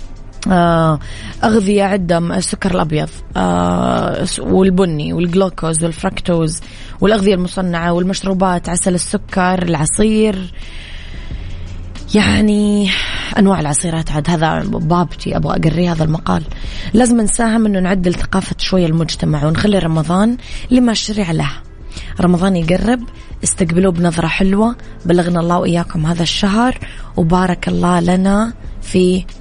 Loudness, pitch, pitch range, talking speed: -15 LUFS, 180 Hz, 160-195 Hz, 105 wpm